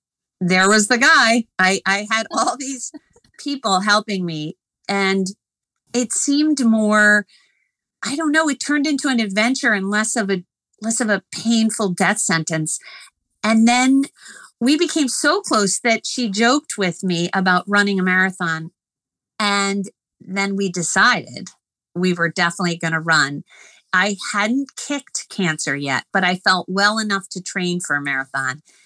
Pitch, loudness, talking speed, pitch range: 205 Hz, -18 LUFS, 150 wpm, 185-240 Hz